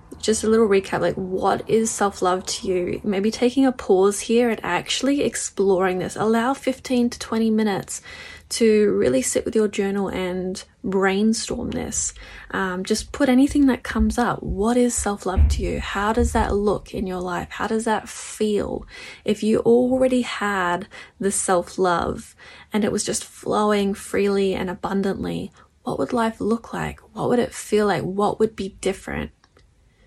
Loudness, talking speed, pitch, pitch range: -22 LUFS, 175 wpm, 205 Hz, 185-225 Hz